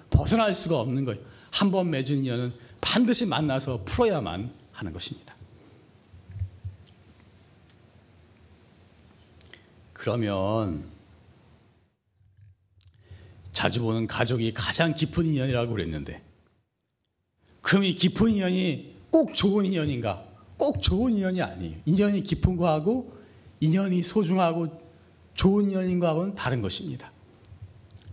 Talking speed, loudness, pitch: 235 characters per minute, -25 LUFS, 115 Hz